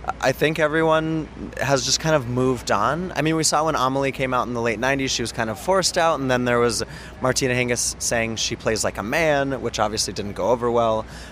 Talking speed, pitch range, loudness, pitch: 240 wpm, 120-150 Hz, -21 LUFS, 130 Hz